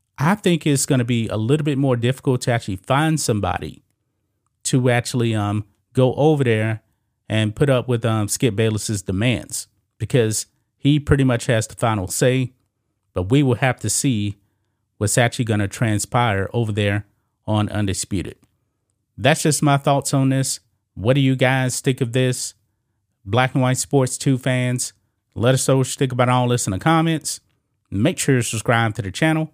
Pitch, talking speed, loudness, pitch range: 120 Hz, 180 wpm, -20 LUFS, 105-130 Hz